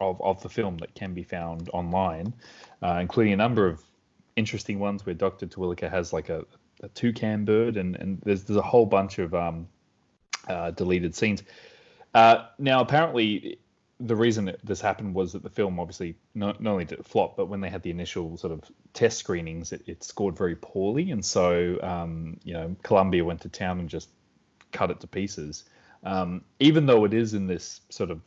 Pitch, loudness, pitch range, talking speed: 95 Hz, -26 LUFS, 85-110 Hz, 200 wpm